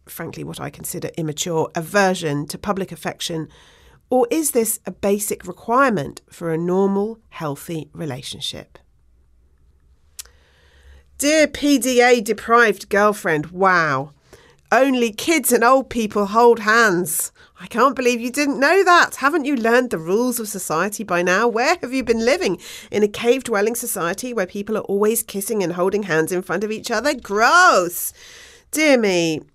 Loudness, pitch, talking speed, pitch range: -18 LUFS, 205 Hz, 150 wpm, 170-245 Hz